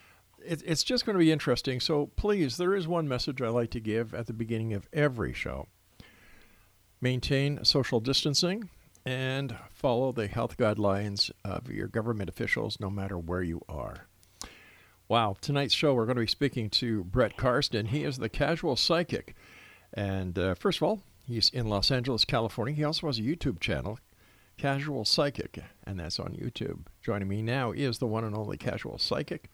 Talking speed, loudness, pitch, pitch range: 175 wpm, -30 LUFS, 120 Hz, 105-140 Hz